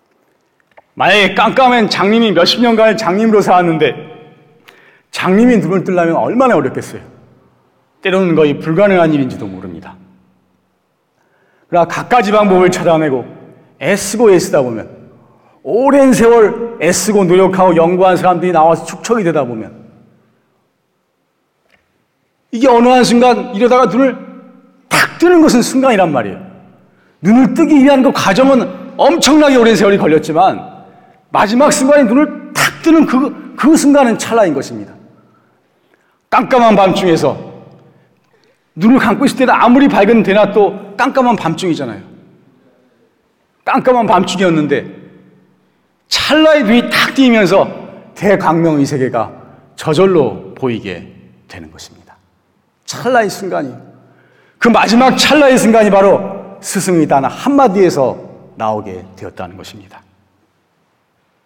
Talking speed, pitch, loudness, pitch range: 275 characters per minute, 195 Hz, -10 LUFS, 150-245 Hz